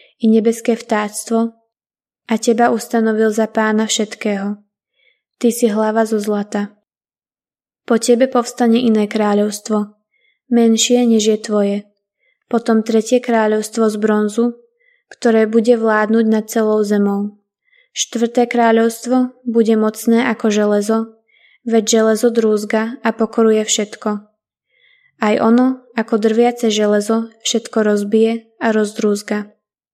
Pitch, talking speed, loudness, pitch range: 225 Hz, 110 wpm, -16 LUFS, 215-235 Hz